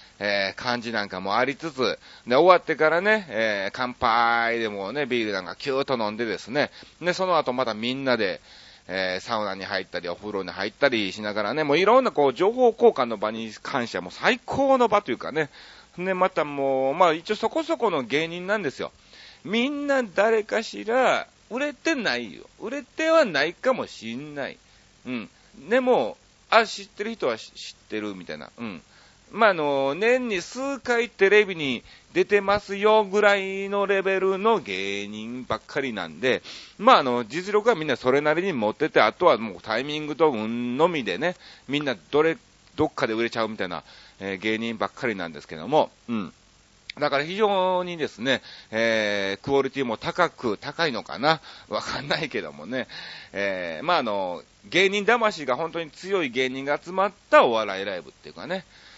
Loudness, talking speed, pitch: -24 LUFS, 345 characters per minute, 150 Hz